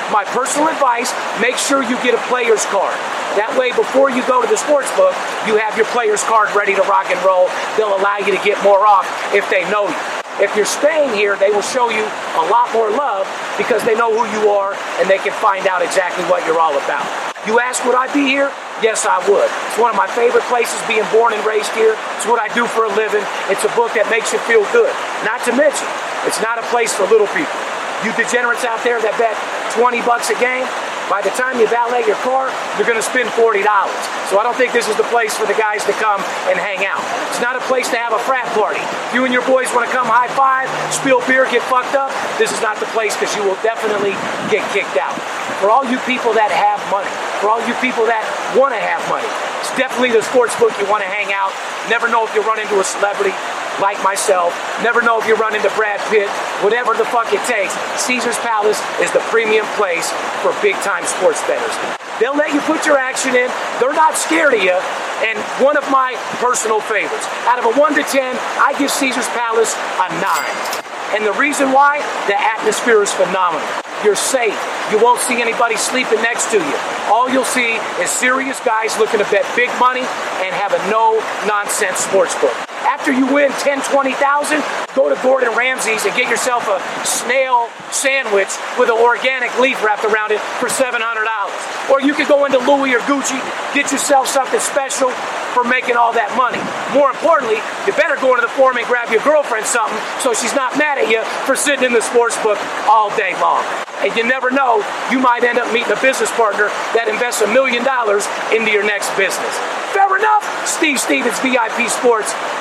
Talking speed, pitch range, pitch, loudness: 215 wpm, 220-270 Hz, 245 Hz, -15 LUFS